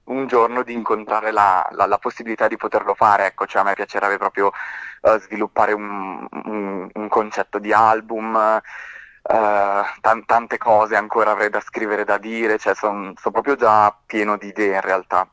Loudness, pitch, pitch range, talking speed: -19 LUFS, 105 Hz, 100-110 Hz, 175 wpm